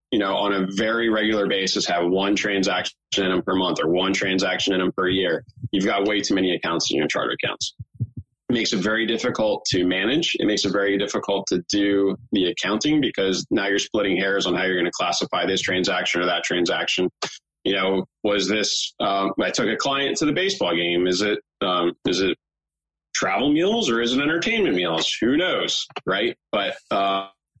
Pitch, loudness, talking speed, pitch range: 100 Hz, -22 LUFS, 200 wpm, 95-105 Hz